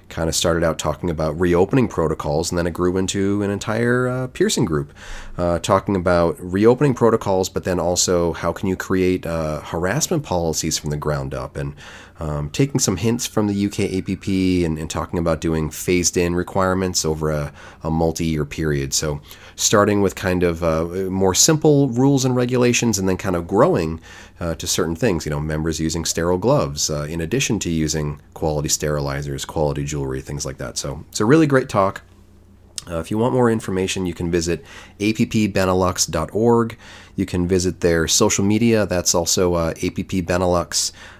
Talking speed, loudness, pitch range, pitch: 180 wpm, -20 LUFS, 80-100 Hz, 90 Hz